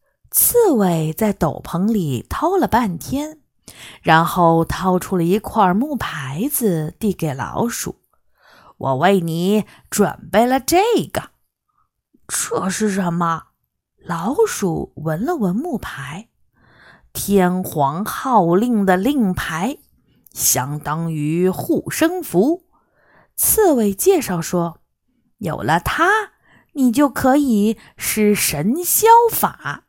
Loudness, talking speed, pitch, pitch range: -18 LUFS, 145 characters per minute, 205 Hz, 170-270 Hz